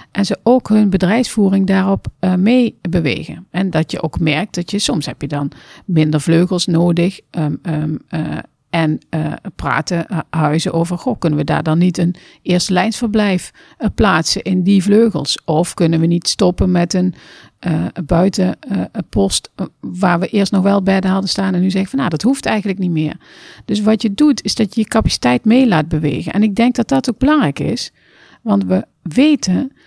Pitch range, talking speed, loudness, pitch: 165-210 Hz, 195 wpm, -16 LUFS, 185 Hz